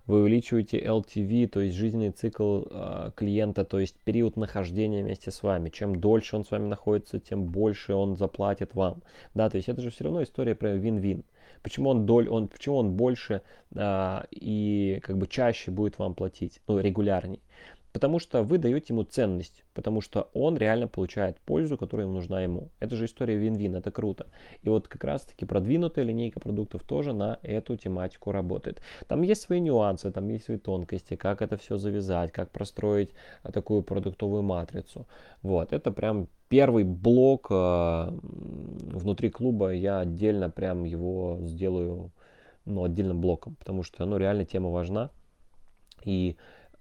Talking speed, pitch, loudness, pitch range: 165 wpm, 100 Hz, -29 LUFS, 95-110 Hz